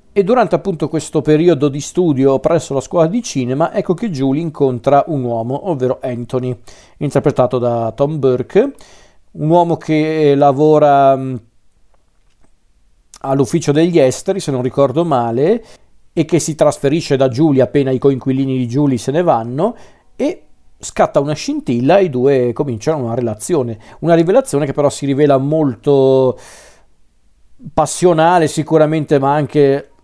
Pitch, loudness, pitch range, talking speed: 145 Hz, -14 LUFS, 130-160 Hz, 140 wpm